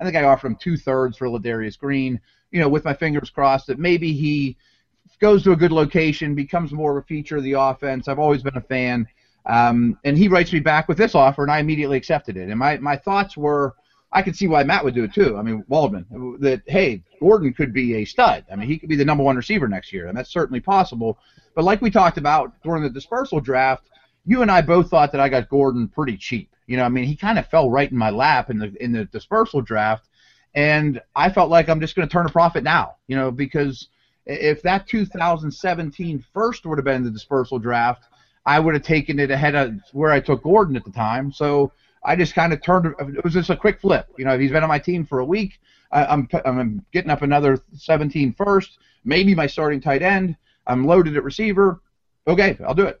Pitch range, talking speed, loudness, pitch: 130-170 Hz, 240 wpm, -19 LUFS, 145 Hz